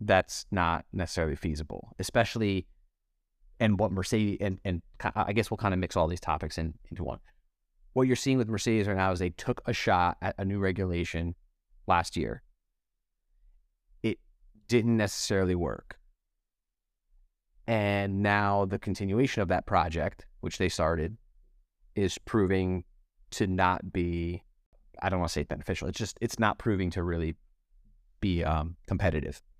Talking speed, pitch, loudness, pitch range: 155 wpm, 95 Hz, -30 LUFS, 85-105 Hz